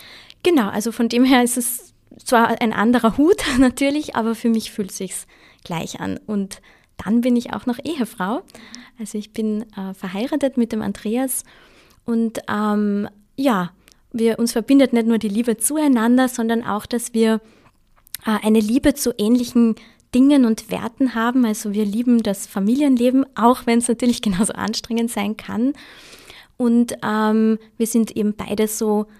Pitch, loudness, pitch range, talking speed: 230 Hz, -19 LUFS, 215-245 Hz, 160 wpm